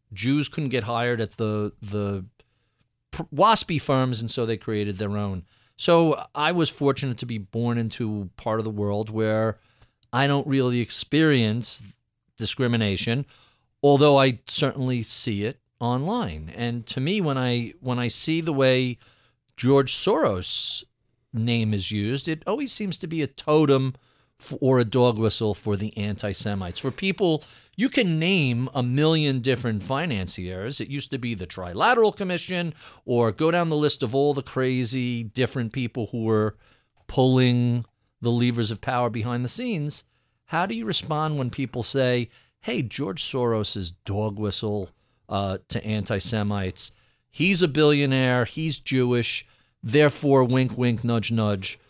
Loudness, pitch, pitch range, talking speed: -24 LUFS, 125 Hz, 110-140 Hz, 155 wpm